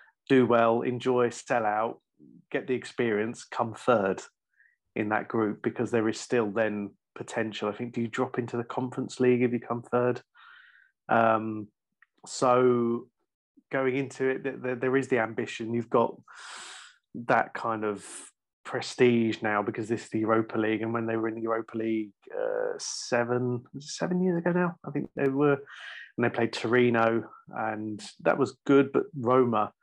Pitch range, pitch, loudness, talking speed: 115-130 Hz, 120 Hz, -28 LUFS, 170 wpm